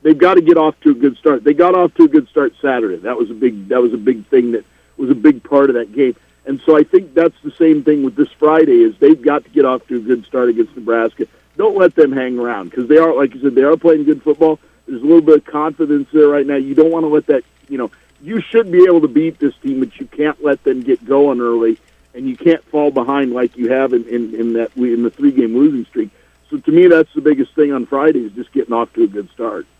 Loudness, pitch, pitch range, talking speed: -13 LUFS, 150 Hz, 130-175 Hz, 280 wpm